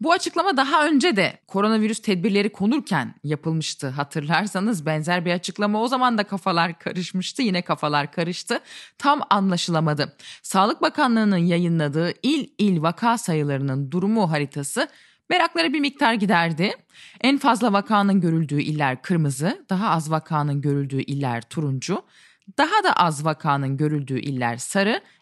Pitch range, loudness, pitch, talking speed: 155-225 Hz, -22 LUFS, 185 Hz, 130 wpm